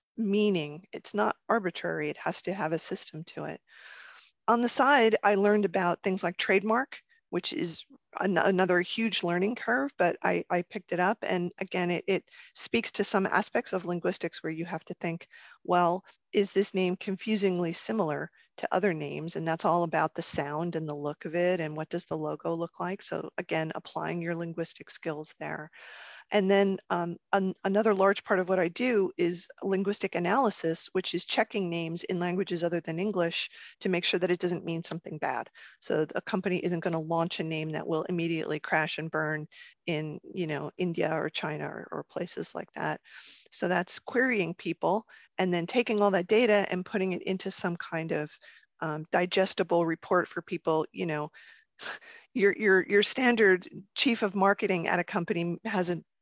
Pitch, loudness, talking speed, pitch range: 180 Hz, -29 LUFS, 190 wpm, 170-200 Hz